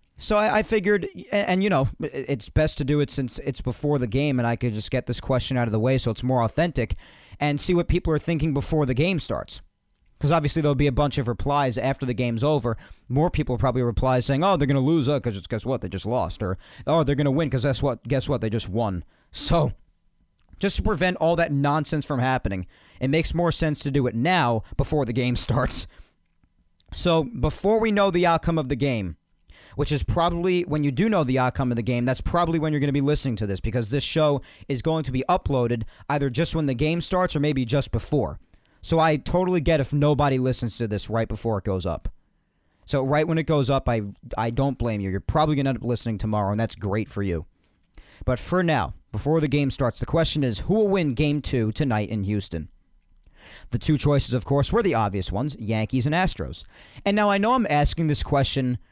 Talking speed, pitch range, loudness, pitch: 235 wpm, 115-155 Hz, -23 LUFS, 135 Hz